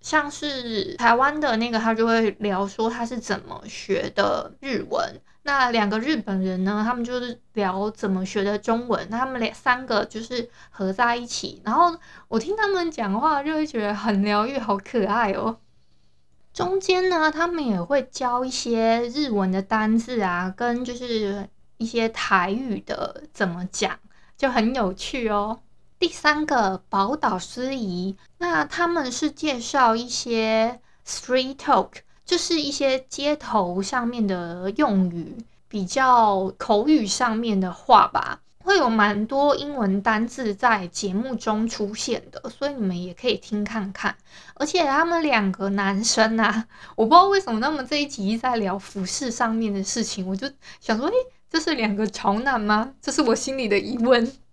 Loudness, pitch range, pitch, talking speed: -23 LUFS, 205-270 Hz, 230 Hz, 245 characters per minute